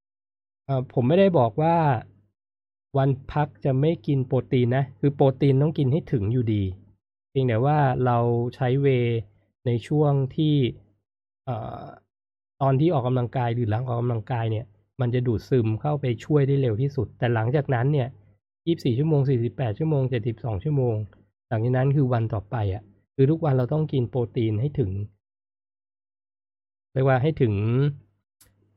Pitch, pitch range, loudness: 125 Hz, 105-140 Hz, -24 LUFS